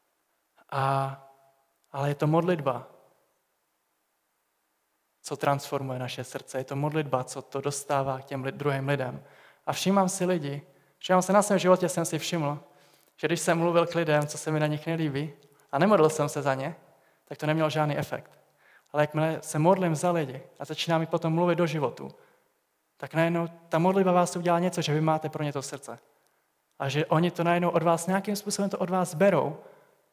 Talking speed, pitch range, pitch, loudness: 185 wpm, 140-175 Hz, 155 Hz, -27 LUFS